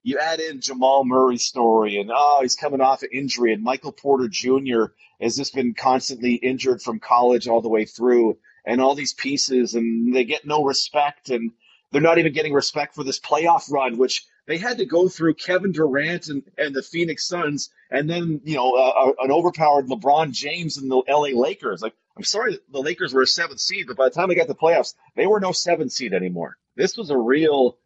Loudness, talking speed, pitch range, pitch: -21 LUFS, 220 wpm, 125-160 Hz, 135 Hz